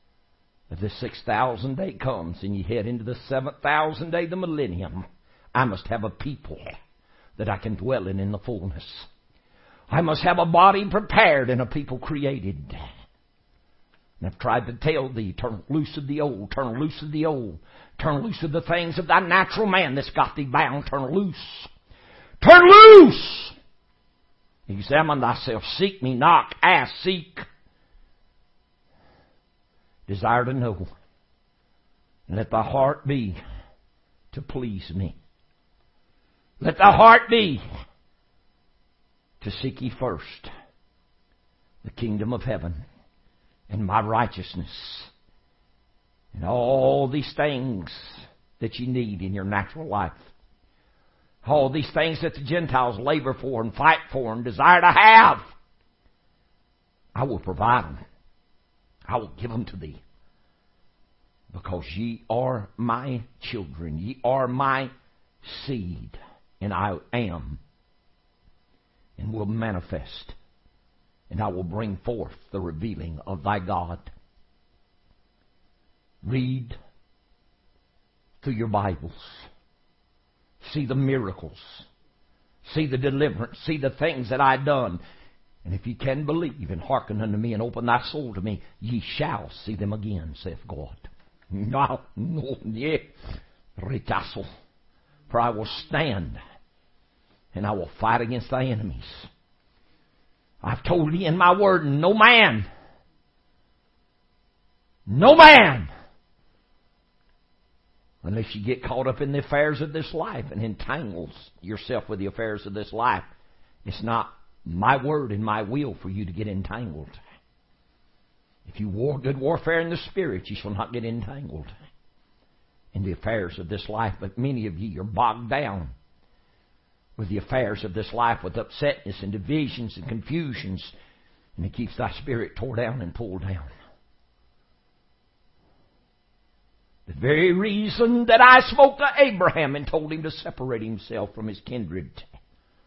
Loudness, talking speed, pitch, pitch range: -21 LUFS, 135 wpm, 115 Hz, 95-140 Hz